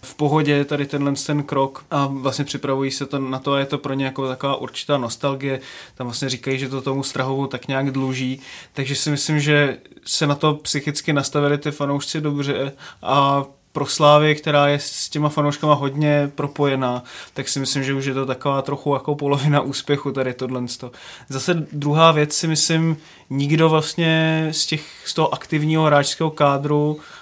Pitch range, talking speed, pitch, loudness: 135-150 Hz, 185 wpm, 140 Hz, -20 LUFS